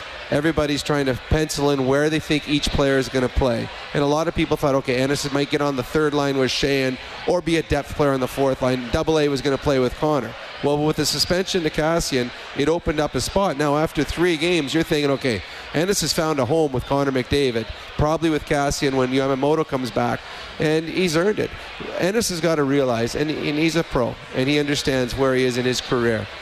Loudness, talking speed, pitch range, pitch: -21 LUFS, 230 wpm, 130-155 Hz, 145 Hz